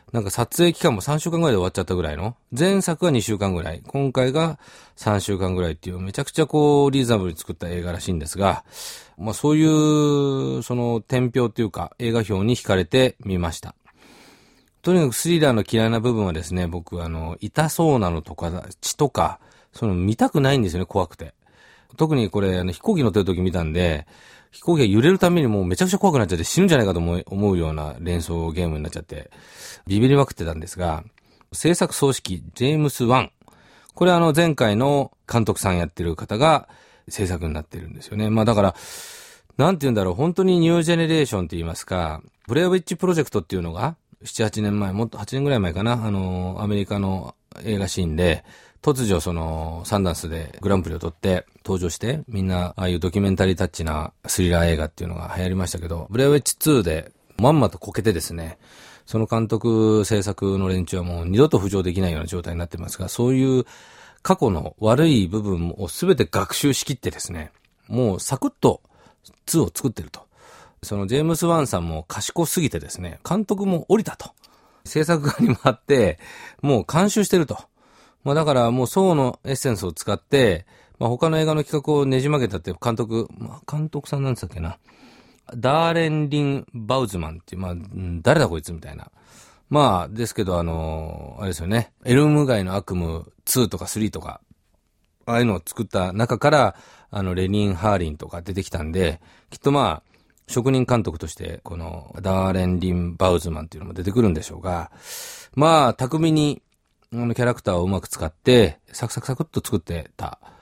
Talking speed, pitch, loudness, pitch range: 400 characters per minute, 105 Hz, -21 LUFS, 90-135 Hz